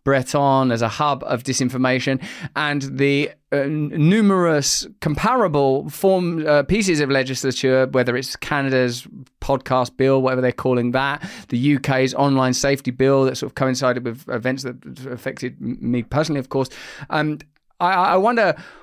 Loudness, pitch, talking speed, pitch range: -20 LUFS, 135 Hz, 150 wpm, 130-145 Hz